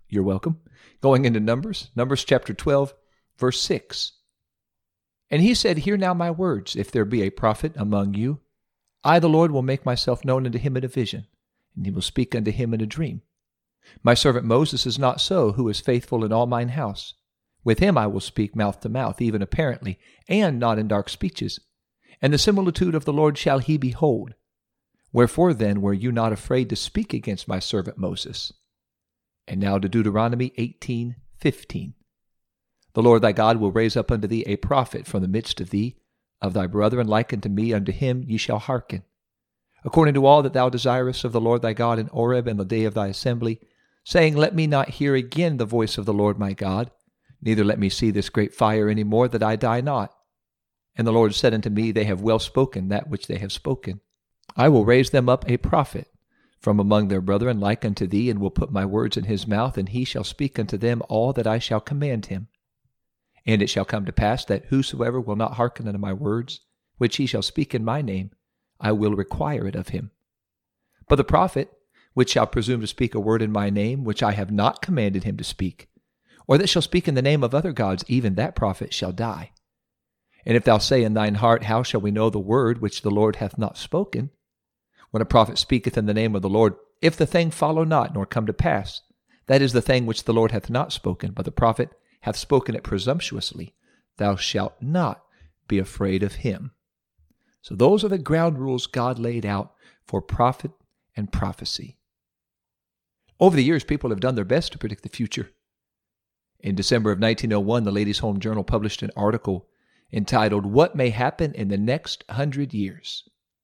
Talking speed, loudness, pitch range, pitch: 205 wpm, -22 LUFS, 105-130 Hz, 115 Hz